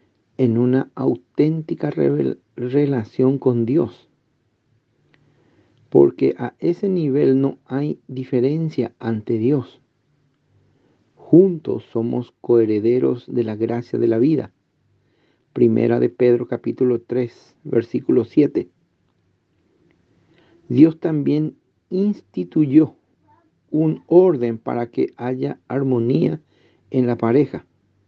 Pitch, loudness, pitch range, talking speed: 125 Hz, -19 LUFS, 115-145 Hz, 95 wpm